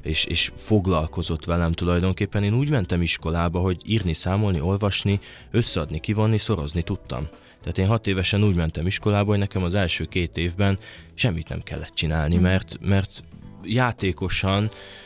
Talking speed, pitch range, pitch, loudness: 145 wpm, 85-105 Hz, 95 Hz, -23 LUFS